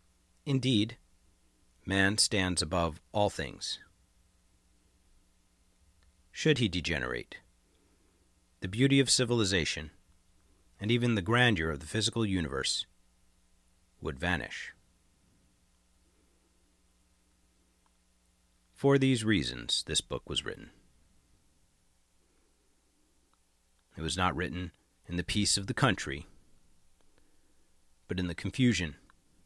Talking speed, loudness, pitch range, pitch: 90 wpm, -30 LUFS, 60-100 Hz, 85 Hz